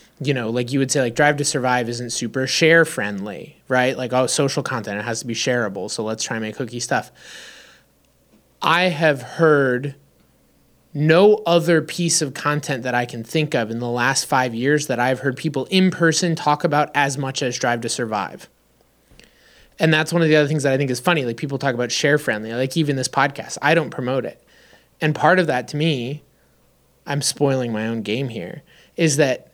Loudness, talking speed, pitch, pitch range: -20 LUFS, 210 wpm, 135 Hz, 120-155 Hz